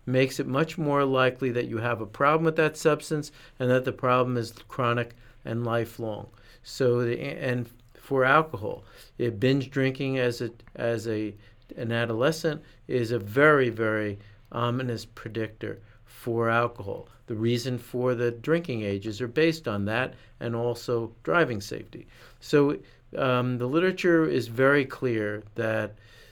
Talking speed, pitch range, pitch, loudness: 150 wpm, 115-135 Hz, 120 Hz, -27 LUFS